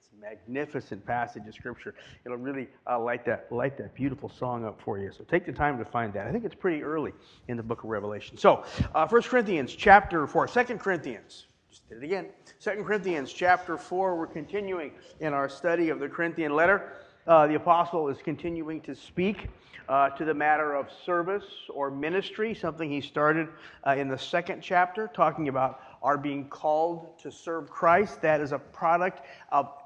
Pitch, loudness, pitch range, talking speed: 155 Hz, -28 LUFS, 135-175 Hz, 190 wpm